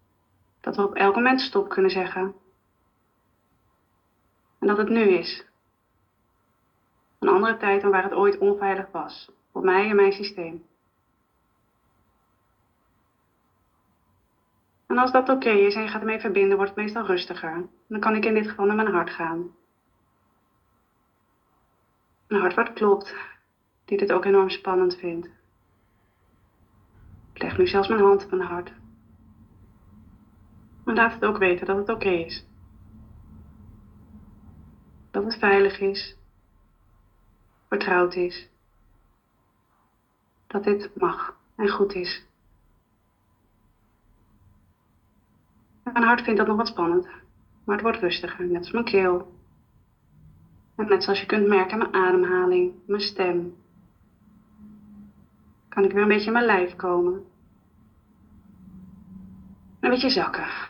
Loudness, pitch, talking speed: -23 LUFS, 175 Hz, 130 wpm